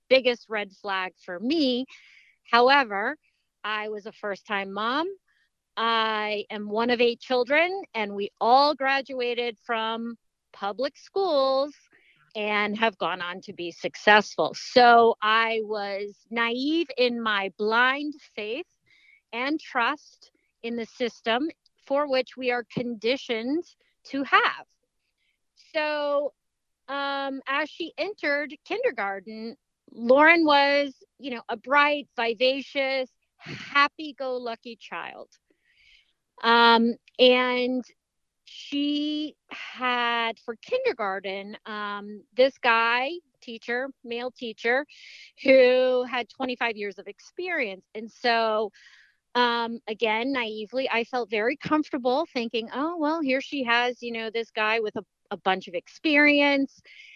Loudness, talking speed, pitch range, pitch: -25 LUFS, 115 wpm, 220-280 Hz, 245 Hz